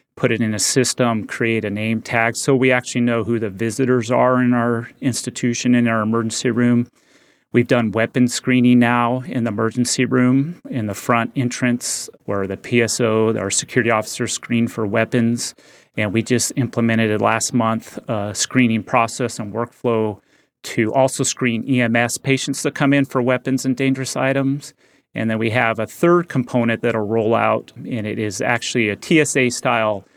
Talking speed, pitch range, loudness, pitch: 175 wpm, 115-130 Hz, -18 LUFS, 120 Hz